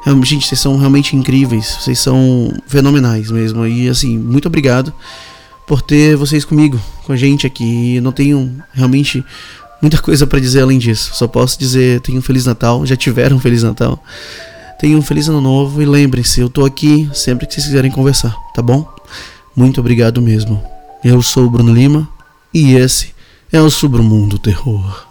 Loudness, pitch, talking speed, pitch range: -11 LUFS, 130 Hz, 175 wpm, 120-145 Hz